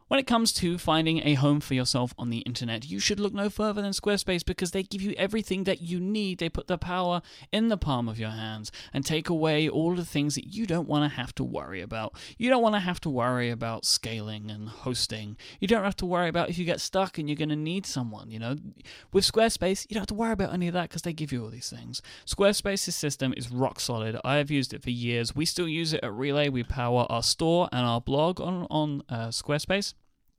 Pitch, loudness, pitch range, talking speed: 155 Hz, -28 LUFS, 125-185 Hz, 250 wpm